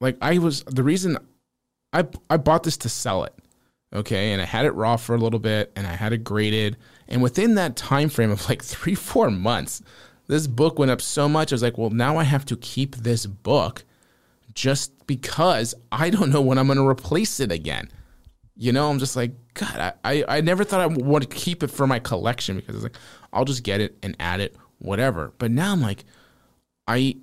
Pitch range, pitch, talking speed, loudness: 110-145 Hz, 125 Hz, 225 wpm, -23 LUFS